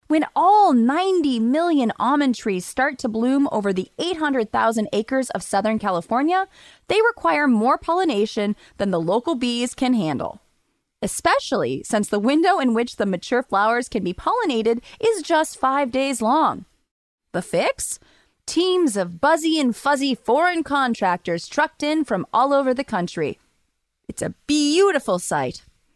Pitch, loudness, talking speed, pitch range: 260 Hz, -21 LUFS, 145 wpm, 215-310 Hz